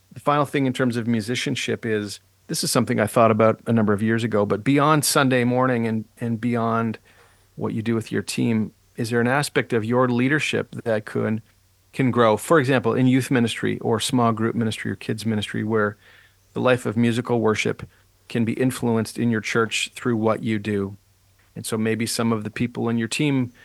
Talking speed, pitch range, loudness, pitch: 205 wpm, 110-125 Hz, -22 LUFS, 115 Hz